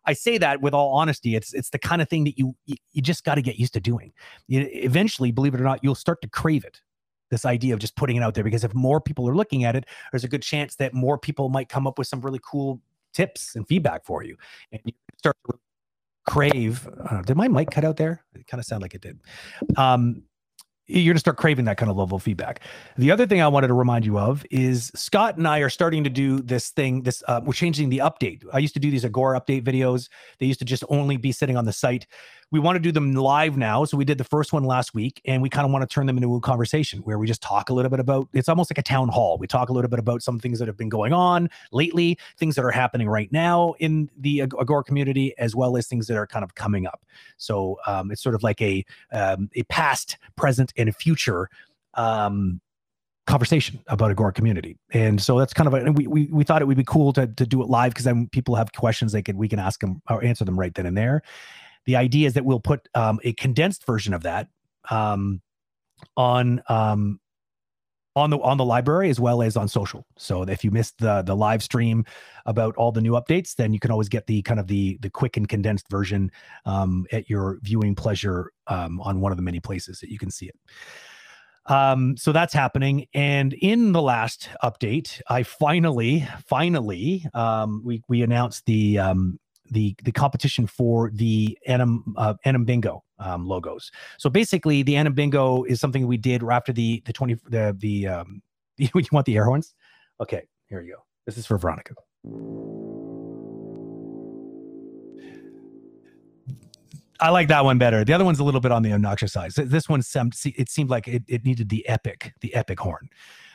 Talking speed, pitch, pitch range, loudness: 225 wpm, 125 Hz, 110-145 Hz, -23 LUFS